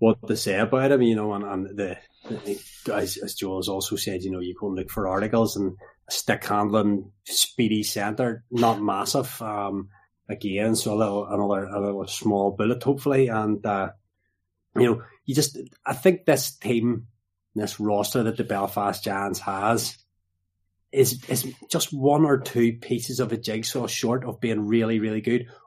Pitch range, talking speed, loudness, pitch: 100-120 Hz, 180 wpm, -25 LUFS, 110 Hz